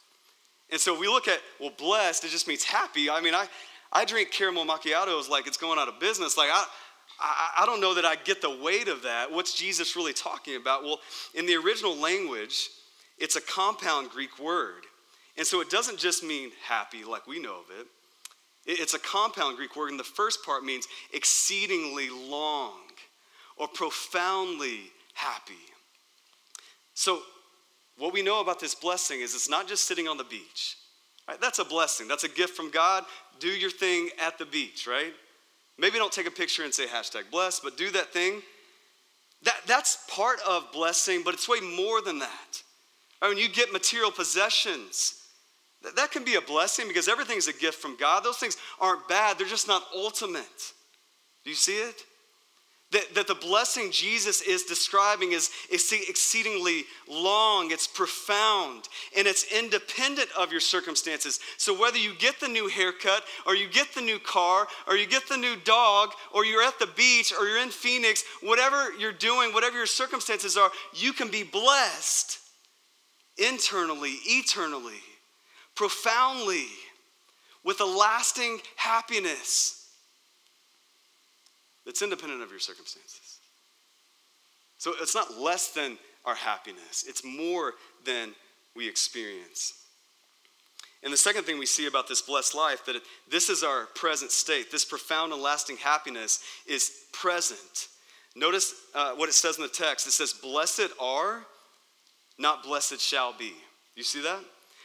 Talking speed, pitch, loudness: 165 wpm, 225 Hz, -26 LUFS